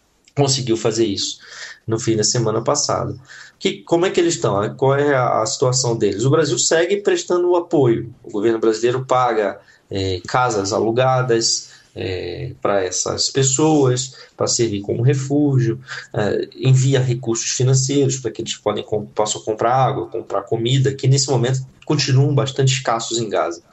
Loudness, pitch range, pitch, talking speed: -18 LUFS, 115-140 Hz, 130 Hz, 150 wpm